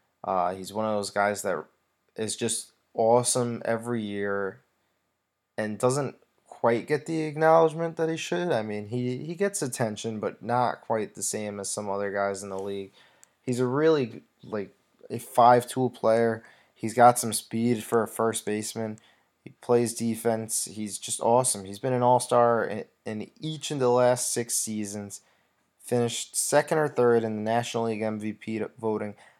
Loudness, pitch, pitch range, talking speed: -27 LUFS, 115 Hz, 105-125 Hz, 170 wpm